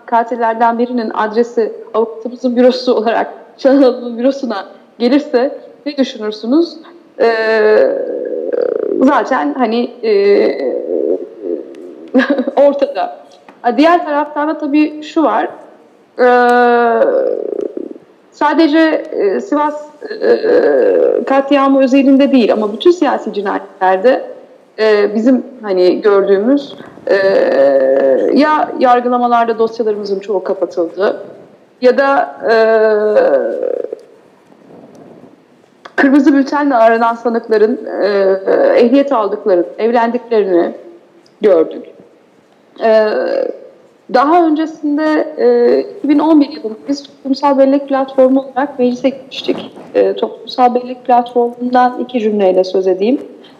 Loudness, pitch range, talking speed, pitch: -13 LUFS, 230-315 Hz, 80 wpm, 265 Hz